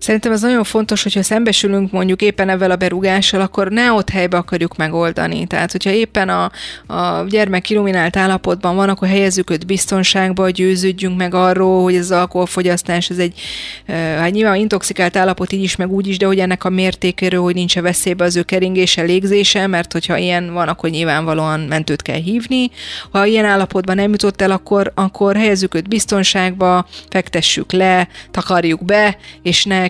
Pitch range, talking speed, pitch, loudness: 180-195 Hz, 175 wpm, 185 Hz, -15 LUFS